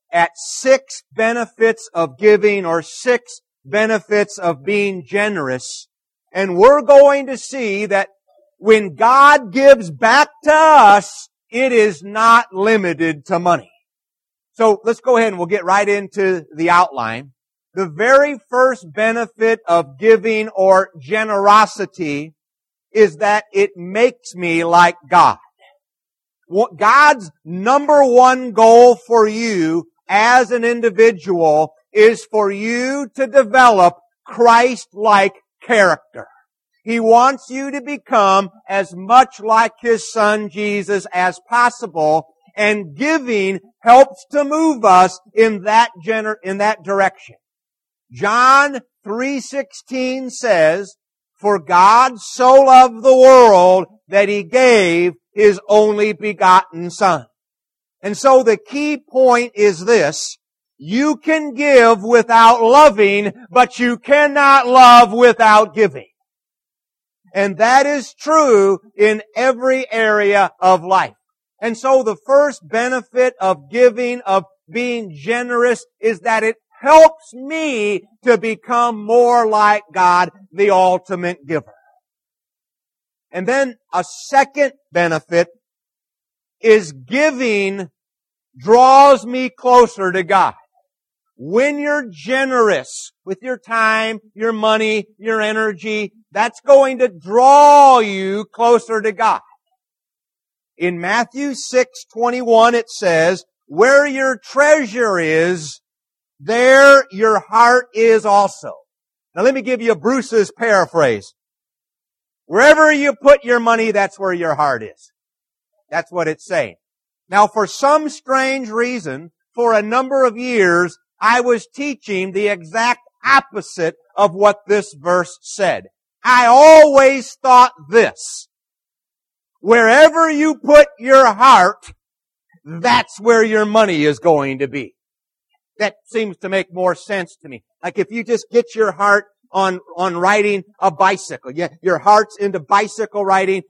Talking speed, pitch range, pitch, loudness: 120 wpm, 195-255 Hz, 220 Hz, -13 LUFS